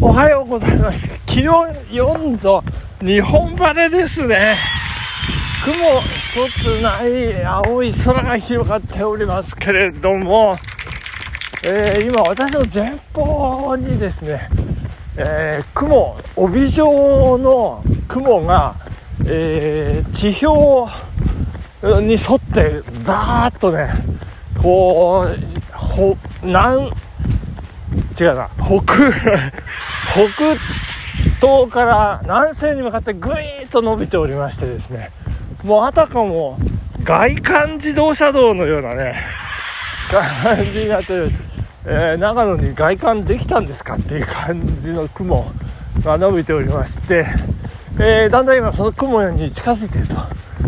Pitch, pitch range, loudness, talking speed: 235 Hz, 185-280 Hz, -16 LUFS, 205 characters per minute